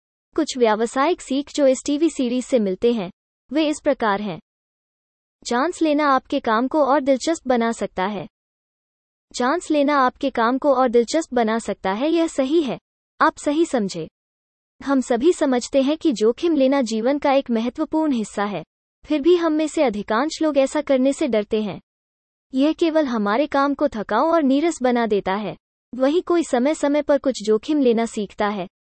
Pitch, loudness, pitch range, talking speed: 270 Hz, -20 LUFS, 225-300 Hz, 180 wpm